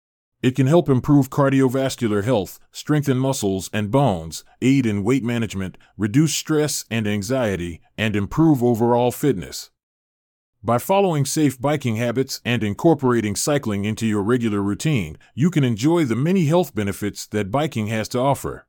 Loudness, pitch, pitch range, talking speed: -20 LUFS, 120 Hz, 105-140 Hz, 150 wpm